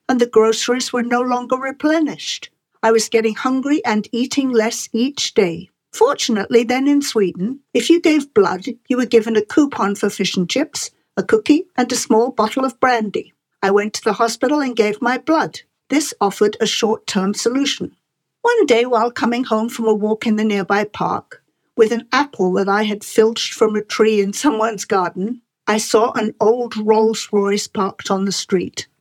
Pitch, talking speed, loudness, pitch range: 230 Hz, 190 wpm, -17 LUFS, 215-260 Hz